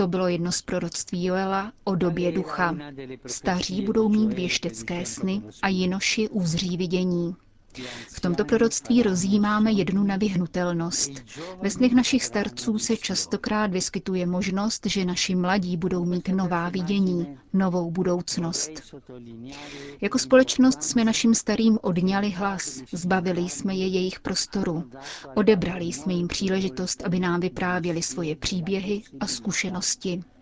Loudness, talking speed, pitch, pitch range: -25 LUFS, 125 wpm, 185 Hz, 175-200 Hz